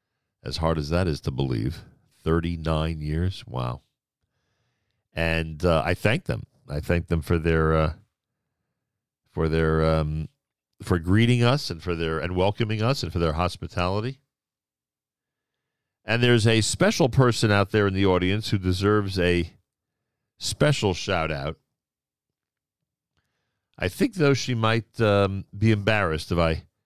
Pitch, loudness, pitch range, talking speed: 95 Hz, -24 LUFS, 85-115 Hz, 140 wpm